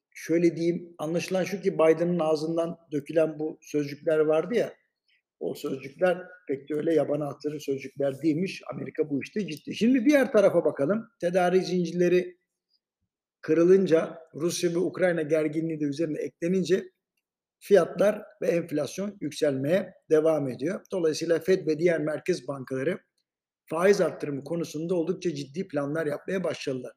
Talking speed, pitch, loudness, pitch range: 130 wpm, 165 Hz, -27 LUFS, 150-180 Hz